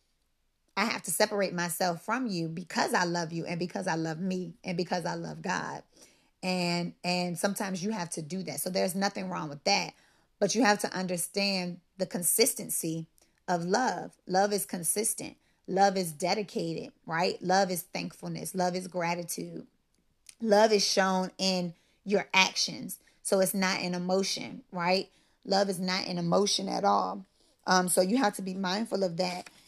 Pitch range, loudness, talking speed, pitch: 175-200 Hz, -29 LUFS, 170 wpm, 185 Hz